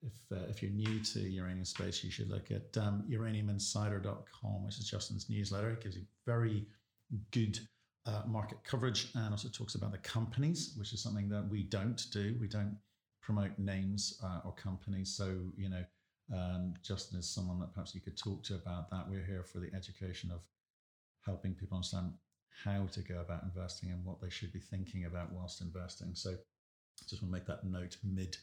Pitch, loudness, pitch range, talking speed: 100 Hz, -41 LUFS, 90-105 Hz, 195 wpm